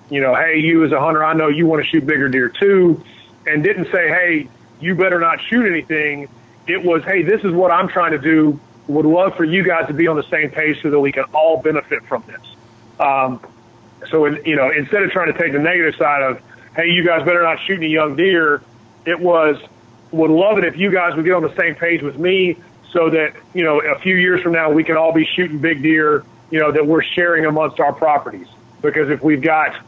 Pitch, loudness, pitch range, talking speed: 155 Hz, -15 LUFS, 145-170 Hz, 245 wpm